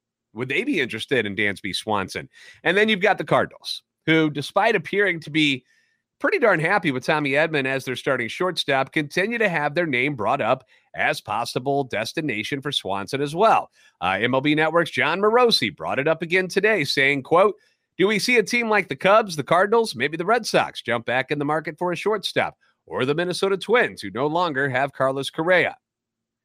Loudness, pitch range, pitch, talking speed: -21 LUFS, 135-195 Hz, 155 Hz, 195 wpm